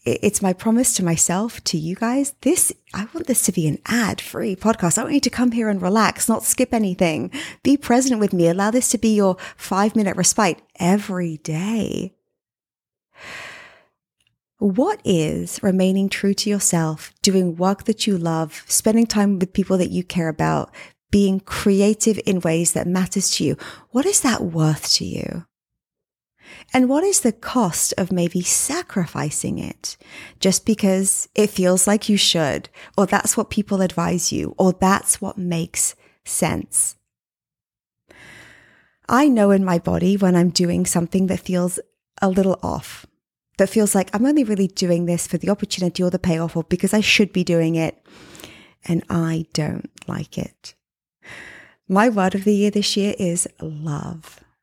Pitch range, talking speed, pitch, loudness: 175-215 Hz, 165 wpm, 195 Hz, -19 LUFS